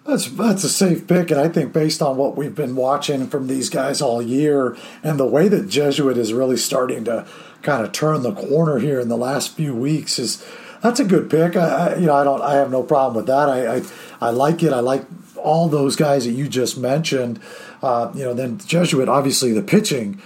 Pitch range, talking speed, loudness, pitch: 130-165 Hz, 230 wpm, -19 LUFS, 140 Hz